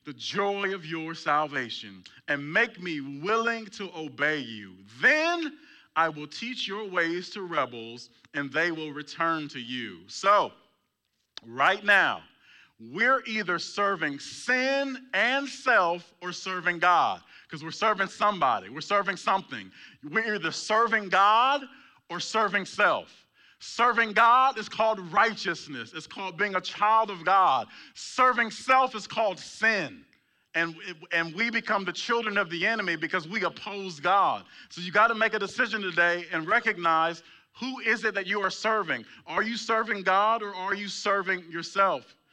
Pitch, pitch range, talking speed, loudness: 195 Hz, 165-220 Hz, 155 wpm, -26 LUFS